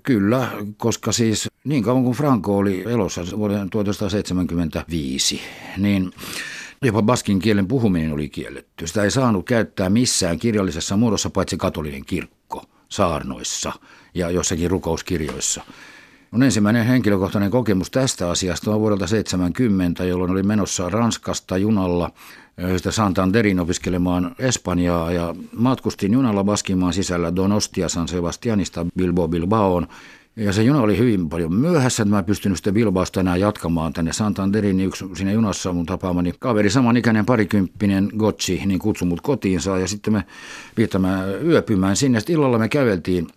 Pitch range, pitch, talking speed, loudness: 90-110 Hz, 100 Hz, 140 wpm, -20 LUFS